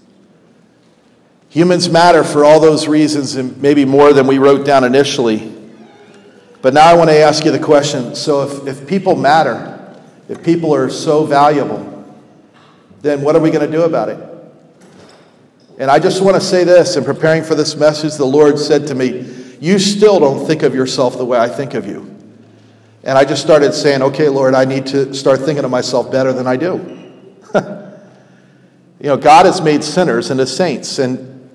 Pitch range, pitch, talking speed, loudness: 130-155 Hz, 145 Hz, 185 wpm, -12 LUFS